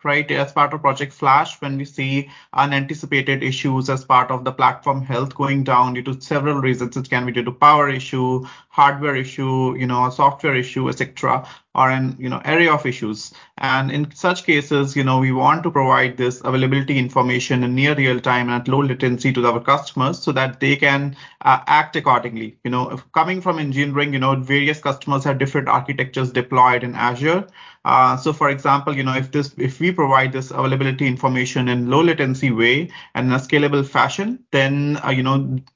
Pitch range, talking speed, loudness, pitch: 130-145 Hz, 200 wpm, -18 LUFS, 135 Hz